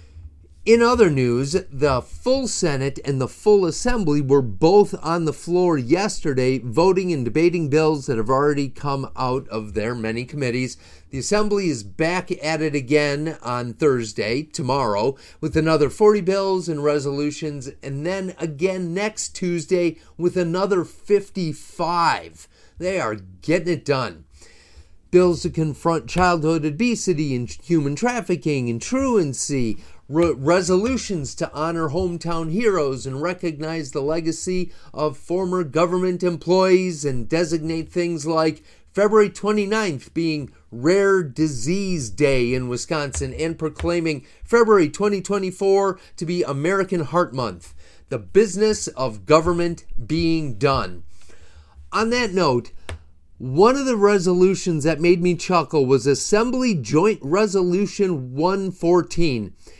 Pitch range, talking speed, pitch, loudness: 135-185 Hz, 125 wpm, 165 Hz, -21 LUFS